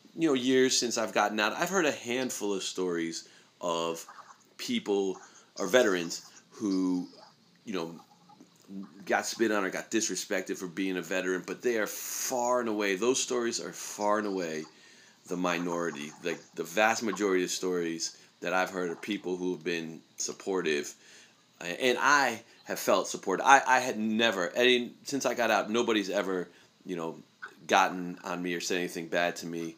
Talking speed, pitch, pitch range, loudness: 175 wpm, 95 Hz, 85-110 Hz, -30 LUFS